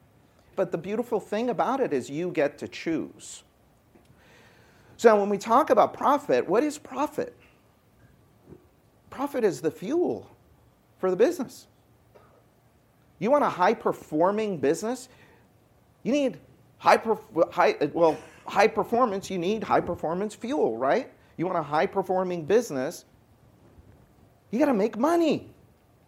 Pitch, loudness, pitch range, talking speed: 195 Hz, -26 LUFS, 155-235 Hz, 125 wpm